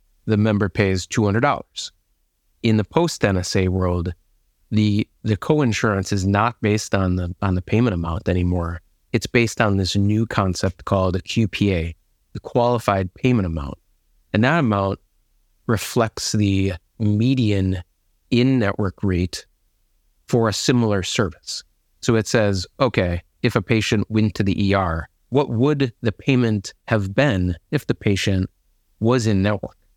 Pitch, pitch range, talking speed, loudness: 105 Hz, 95-115 Hz, 140 wpm, -21 LUFS